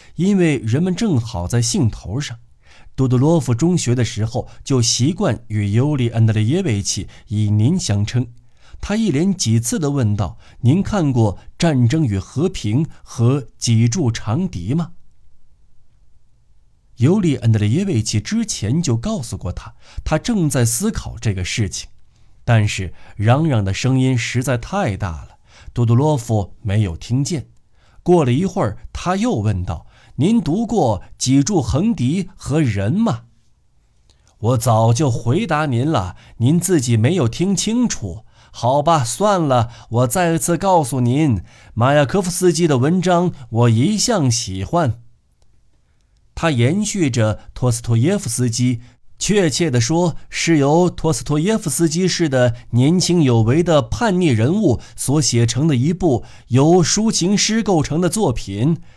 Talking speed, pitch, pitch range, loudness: 215 characters per minute, 125 Hz, 115-165 Hz, -18 LUFS